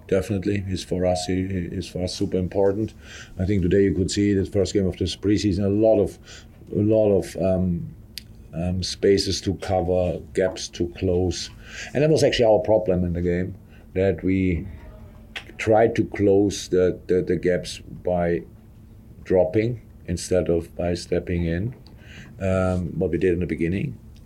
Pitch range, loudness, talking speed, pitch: 90-105 Hz, -23 LUFS, 165 wpm, 95 Hz